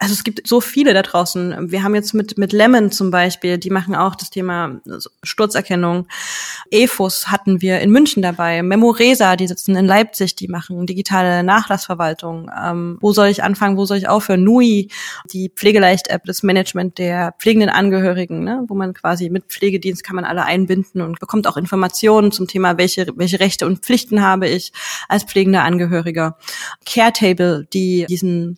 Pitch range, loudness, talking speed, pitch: 180-205 Hz, -15 LUFS, 170 wpm, 190 Hz